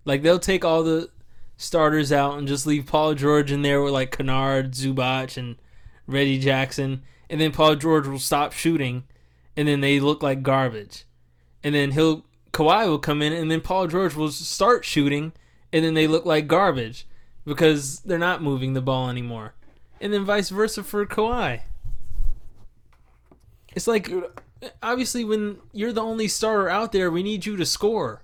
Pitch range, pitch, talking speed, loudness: 135-180 Hz, 150 Hz, 175 wpm, -22 LUFS